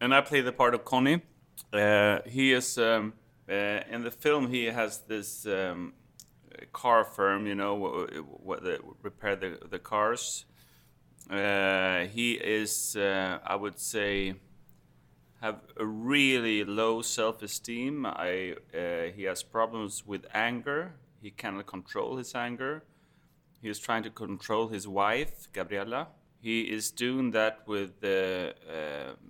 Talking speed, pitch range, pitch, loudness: 145 wpm, 100-125 Hz, 110 Hz, -30 LUFS